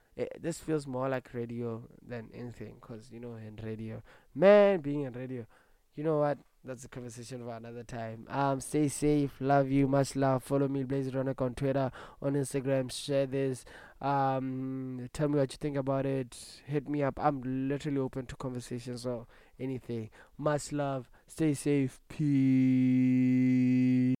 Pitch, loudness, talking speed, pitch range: 130 Hz, -31 LUFS, 165 wpm, 125-140 Hz